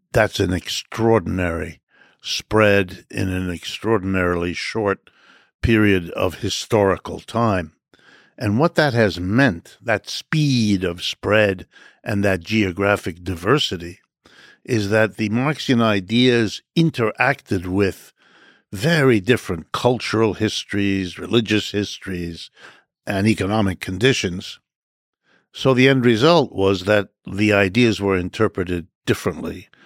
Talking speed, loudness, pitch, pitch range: 105 wpm, -19 LUFS, 105 Hz, 95-115 Hz